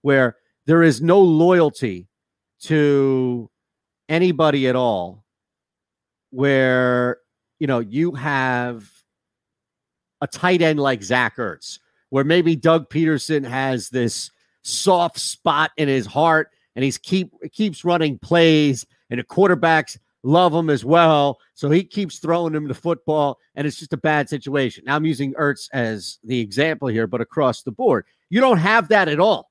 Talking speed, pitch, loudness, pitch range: 155 wpm, 145 Hz, -19 LUFS, 125-165 Hz